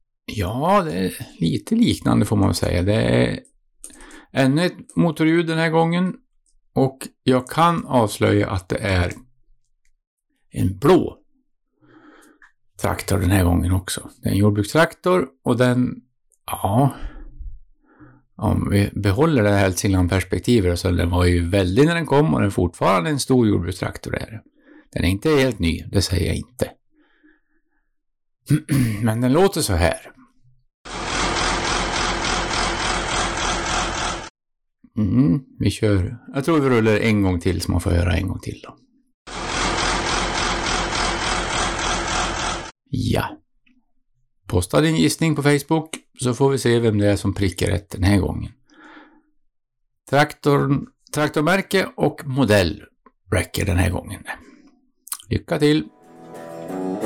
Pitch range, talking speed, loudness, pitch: 100-155 Hz, 130 wpm, -20 LUFS, 120 Hz